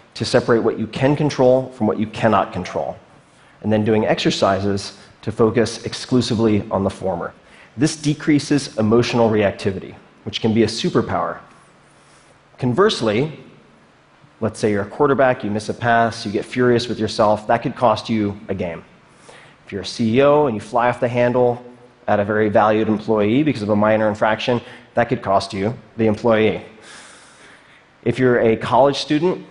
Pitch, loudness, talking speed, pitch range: 115 Hz, -18 LUFS, 165 wpm, 105-125 Hz